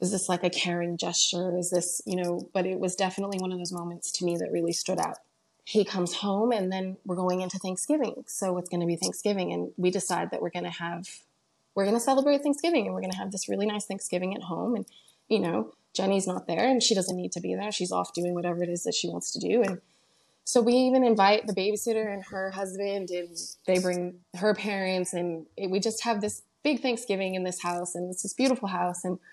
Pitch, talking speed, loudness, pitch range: 185 Hz, 245 wpm, -28 LUFS, 180-210 Hz